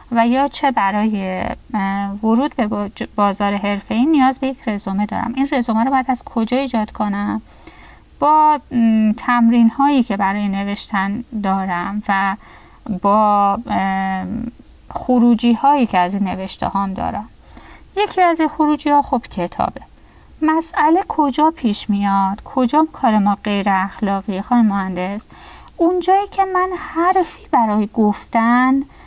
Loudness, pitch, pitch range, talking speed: -17 LUFS, 230 Hz, 200-275 Hz, 130 wpm